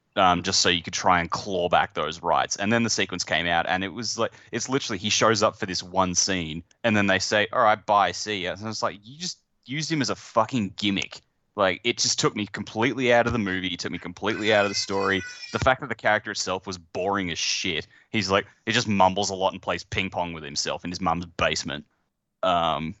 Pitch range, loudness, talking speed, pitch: 95-115 Hz, -24 LUFS, 250 wpm, 105 Hz